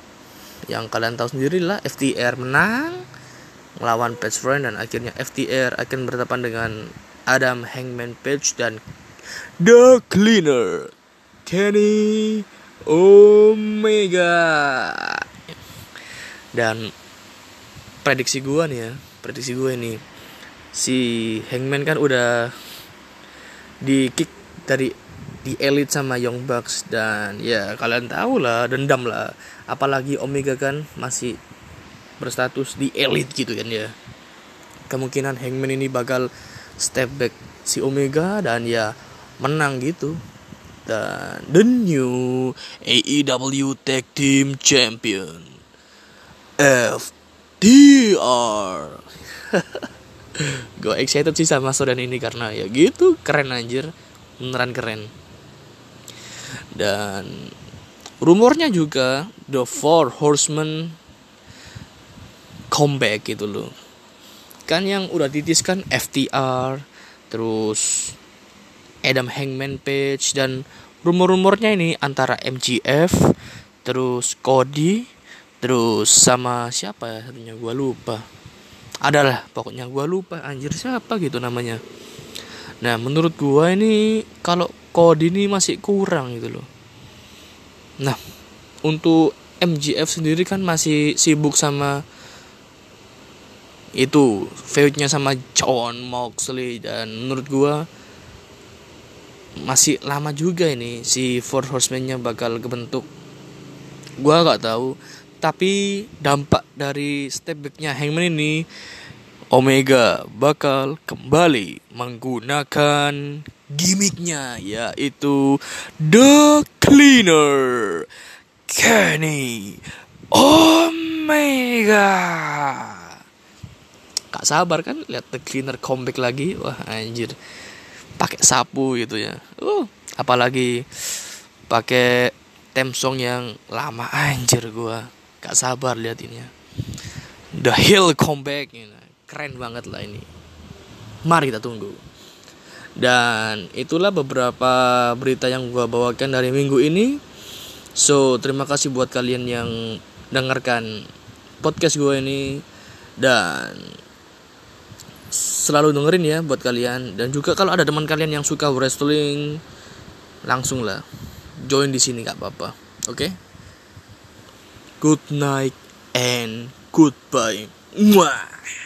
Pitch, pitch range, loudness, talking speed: 135 Hz, 120-155 Hz, -18 LUFS, 100 wpm